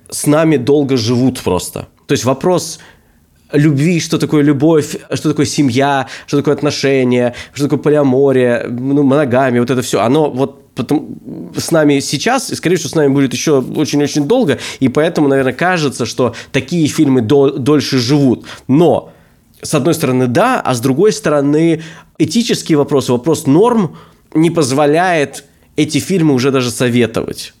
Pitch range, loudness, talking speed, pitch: 130-155 Hz, -13 LUFS, 155 wpm, 145 Hz